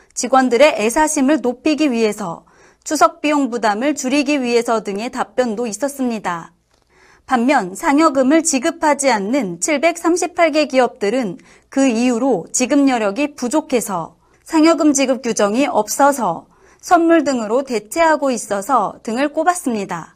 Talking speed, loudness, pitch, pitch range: 290 characters per minute, -16 LUFS, 270 Hz, 230-305 Hz